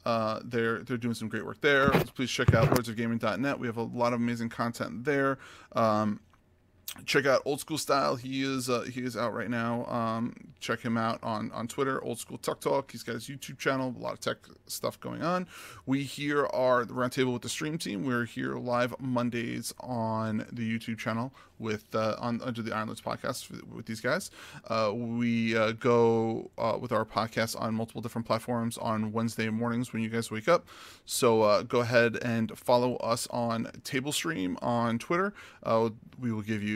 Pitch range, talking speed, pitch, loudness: 115-125 Hz, 200 wpm, 115 Hz, -30 LUFS